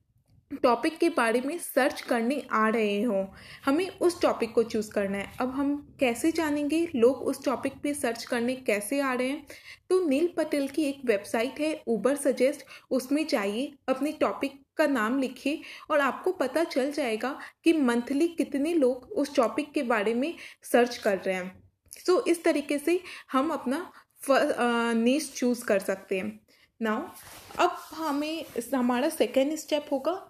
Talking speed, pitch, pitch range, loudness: 165 wpm, 275 Hz, 240-305 Hz, -28 LUFS